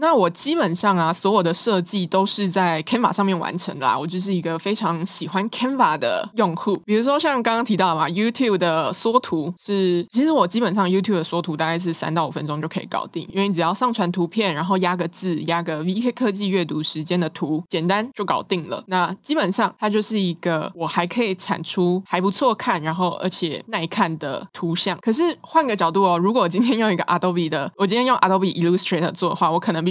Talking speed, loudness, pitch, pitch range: 400 characters per minute, -21 LUFS, 185 Hz, 170-210 Hz